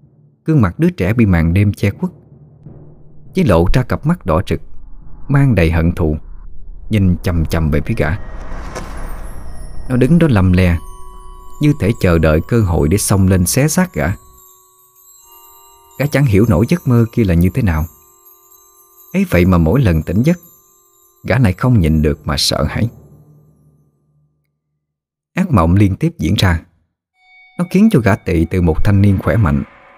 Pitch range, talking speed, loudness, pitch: 80-130 Hz, 170 wpm, -14 LUFS, 100 Hz